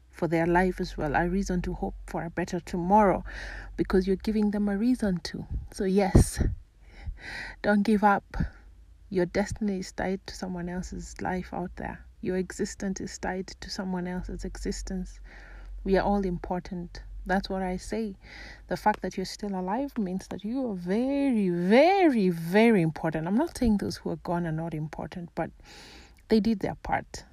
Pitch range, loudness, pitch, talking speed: 180-205 Hz, -28 LUFS, 190 Hz, 175 wpm